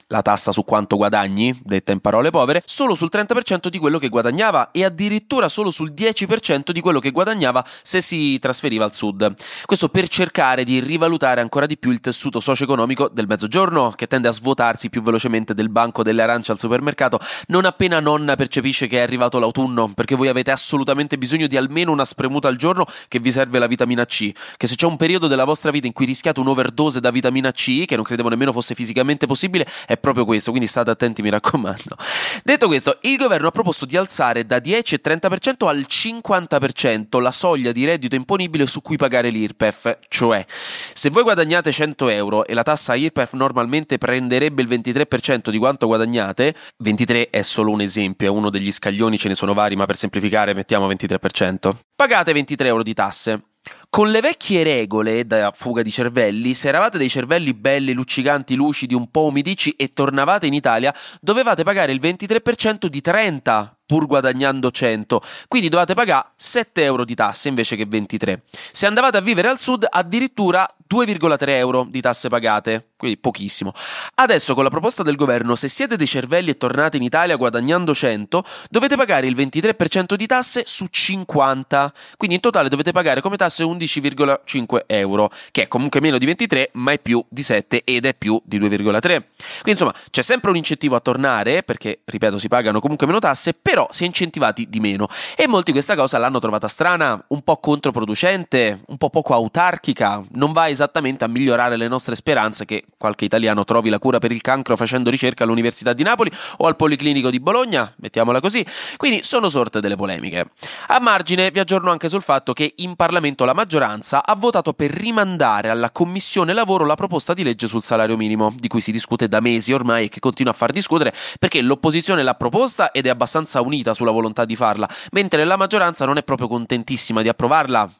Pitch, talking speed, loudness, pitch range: 135 Hz, 190 wpm, -18 LUFS, 115-165 Hz